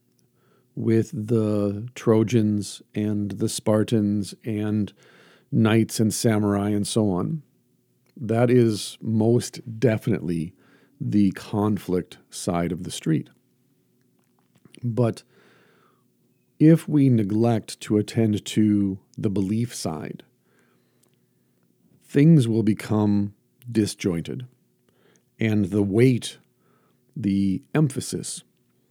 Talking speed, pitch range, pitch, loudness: 85 wpm, 100-120 Hz, 110 Hz, -23 LUFS